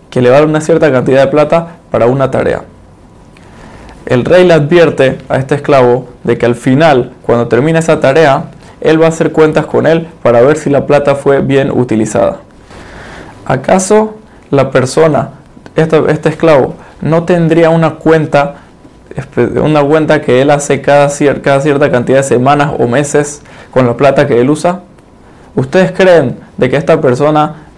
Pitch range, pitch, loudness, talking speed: 130-160 Hz, 145 Hz, -9 LUFS, 170 wpm